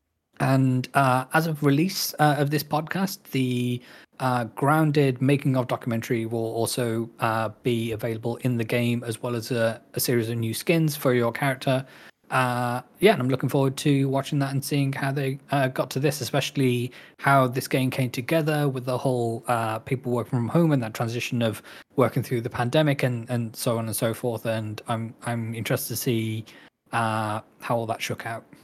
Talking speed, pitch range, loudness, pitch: 195 wpm, 115-140 Hz, -25 LUFS, 125 Hz